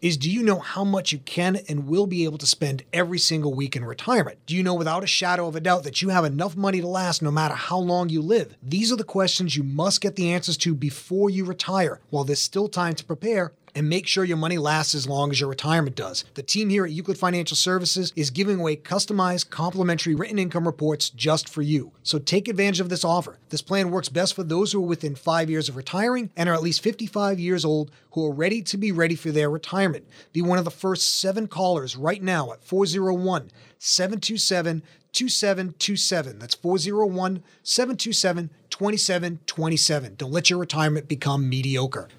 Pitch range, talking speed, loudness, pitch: 155-190 Hz, 210 wpm, -23 LUFS, 175 Hz